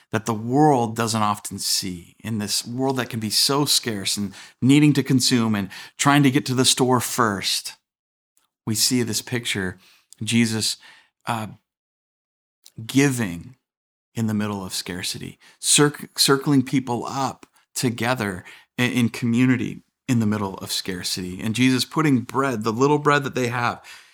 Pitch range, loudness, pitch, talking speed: 105-130 Hz, -21 LUFS, 120 Hz, 150 wpm